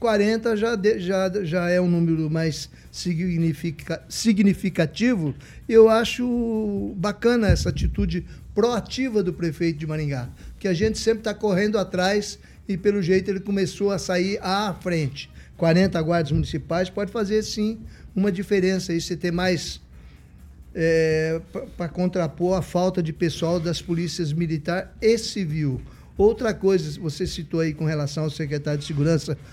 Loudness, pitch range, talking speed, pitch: -23 LUFS, 160-205 Hz, 145 wpm, 180 Hz